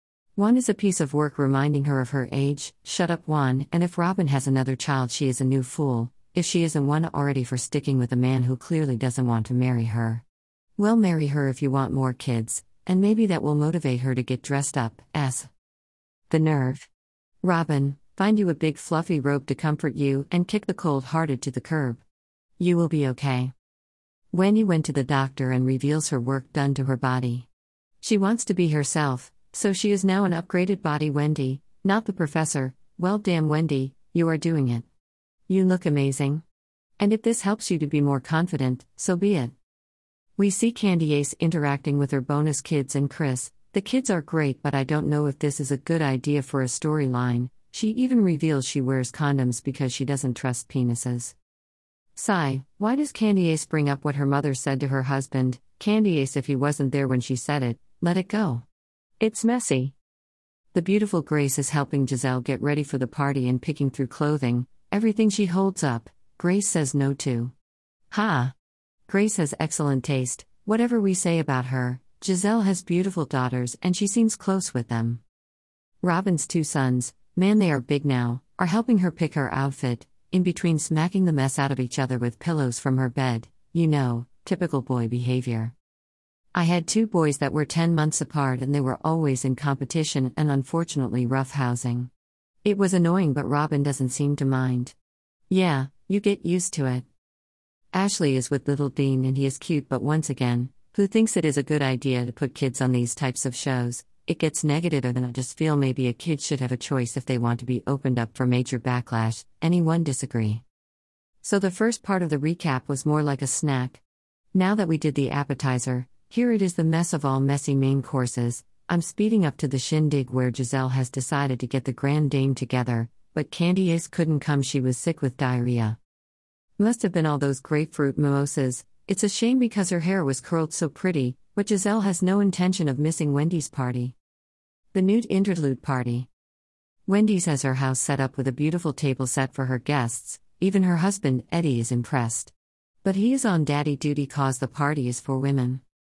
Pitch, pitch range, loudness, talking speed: 140 Hz, 130-165 Hz, -25 LUFS, 200 wpm